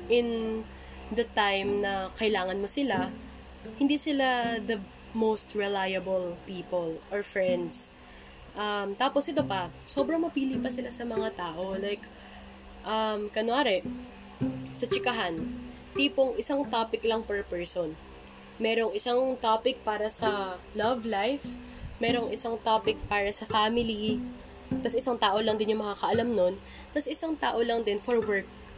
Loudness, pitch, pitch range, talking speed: -29 LUFS, 220 Hz, 195-240 Hz, 135 wpm